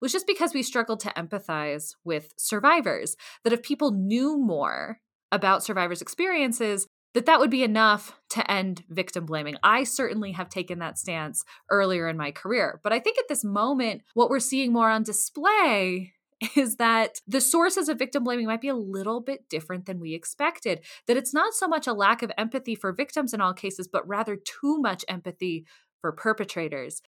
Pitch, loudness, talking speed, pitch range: 220 Hz, -26 LUFS, 190 wpm, 185-270 Hz